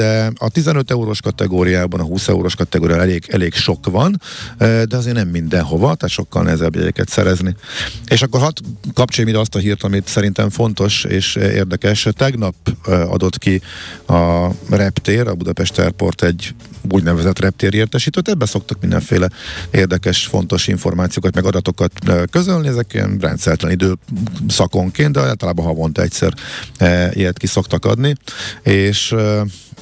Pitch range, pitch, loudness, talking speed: 90-110 Hz, 95 Hz, -16 LUFS, 140 wpm